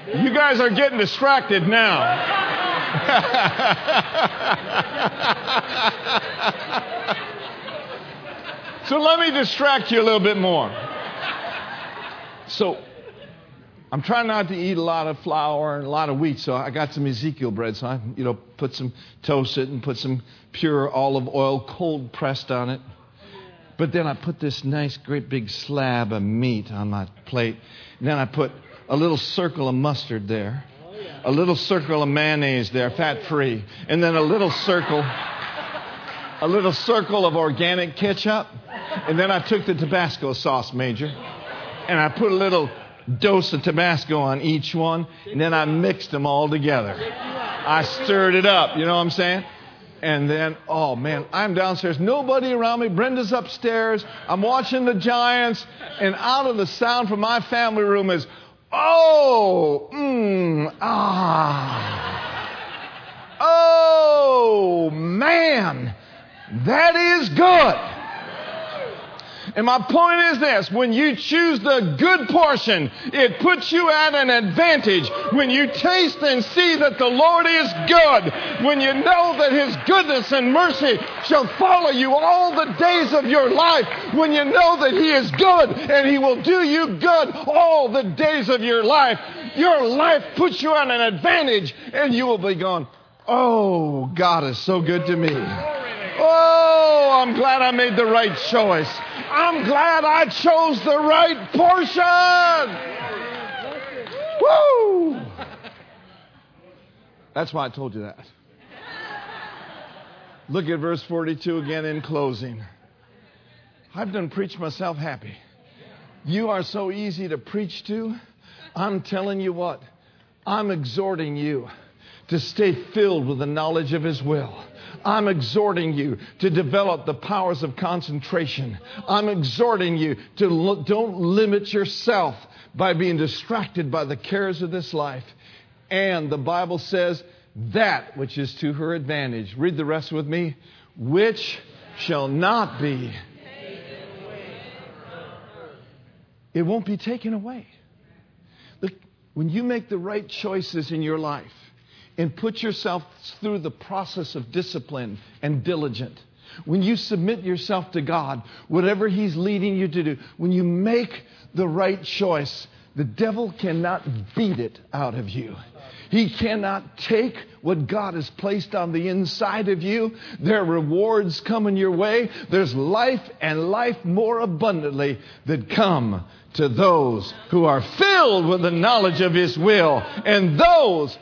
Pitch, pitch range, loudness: 185 Hz, 150-240 Hz, -20 LUFS